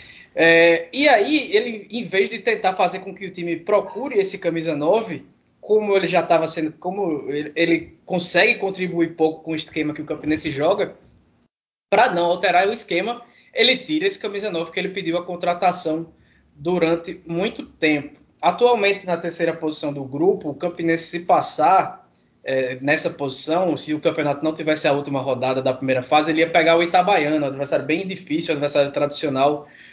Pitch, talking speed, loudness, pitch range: 165 Hz, 180 wpm, -20 LUFS, 155-190 Hz